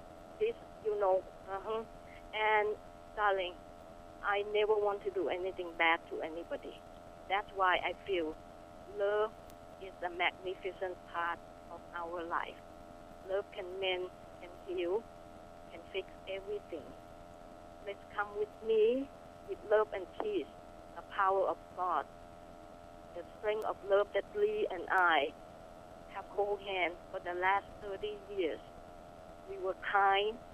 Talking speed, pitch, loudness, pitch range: 130 wpm, 205 Hz, -35 LUFS, 190-220 Hz